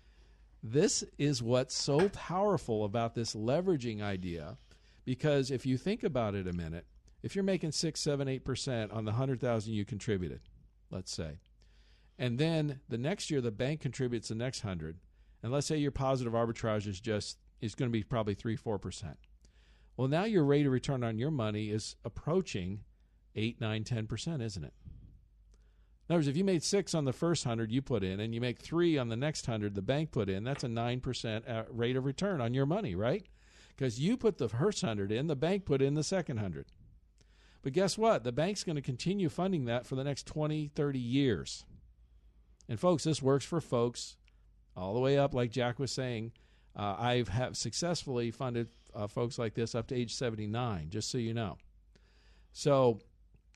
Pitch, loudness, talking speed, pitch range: 120 Hz, -34 LUFS, 195 wpm, 110-145 Hz